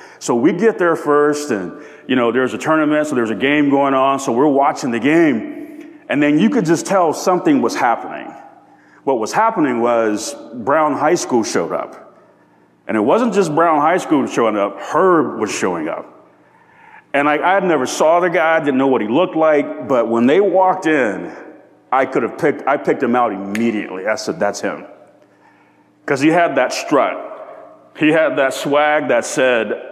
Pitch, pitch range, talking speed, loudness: 155 Hz, 135-195 Hz, 195 wpm, -16 LUFS